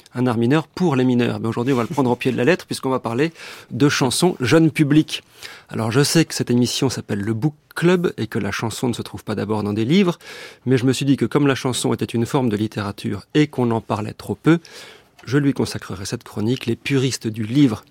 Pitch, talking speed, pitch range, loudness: 125 Hz, 250 wpm, 115-145 Hz, -20 LUFS